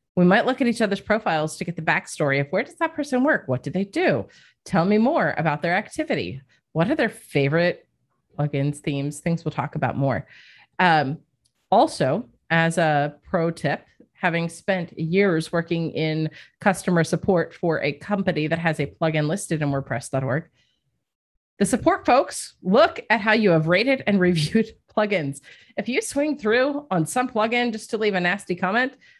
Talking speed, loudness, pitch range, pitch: 175 wpm, -22 LUFS, 155-215 Hz, 175 Hz